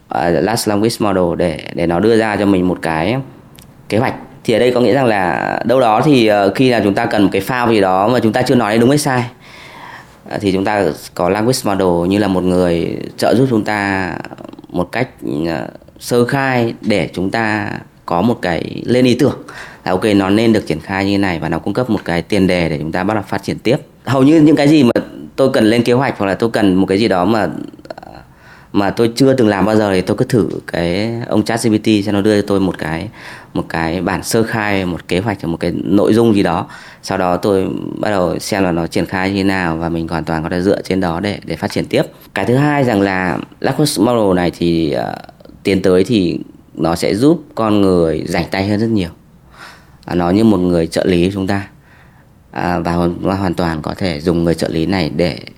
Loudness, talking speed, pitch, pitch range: -15 LUFS, 245 wpm, 100 Hz, 90-115 Hz